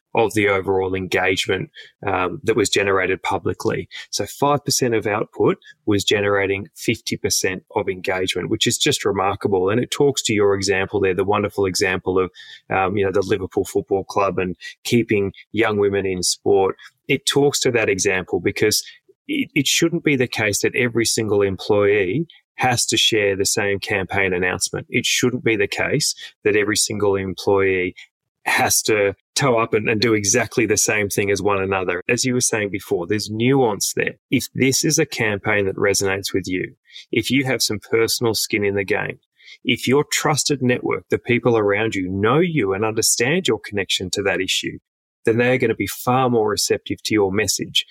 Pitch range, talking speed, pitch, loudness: 100-130 Hz, 185 wpm, 110 Hz, -19 LUFS